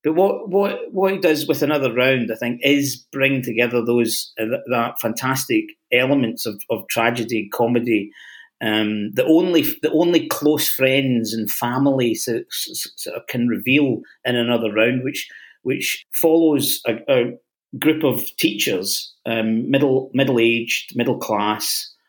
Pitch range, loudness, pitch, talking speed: 115-150 Hz, -19 LUFS, 130 Hz, 150 wpm